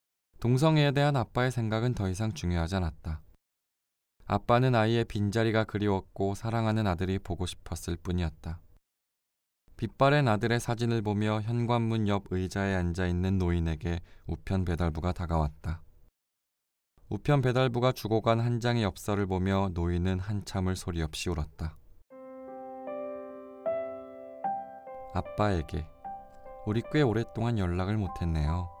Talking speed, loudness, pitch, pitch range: 285 characters per minute, -30 LUFS, 95 Hz, 85-115 Hz